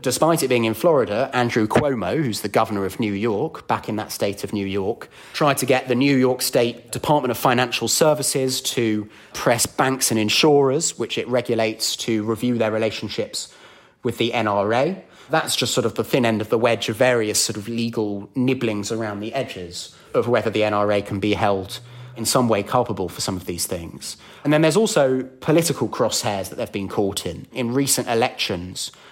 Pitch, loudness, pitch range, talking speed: 115 Hz, -21 LUFS, 105-130 Hz, 195 wpm